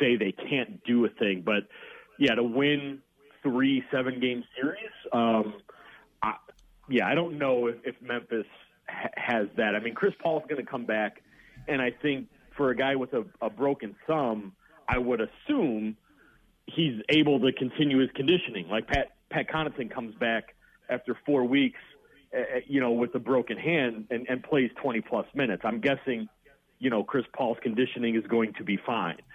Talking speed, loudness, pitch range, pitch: 180 wpm, -28 LUFS, 120-140 Hz, 130 Hz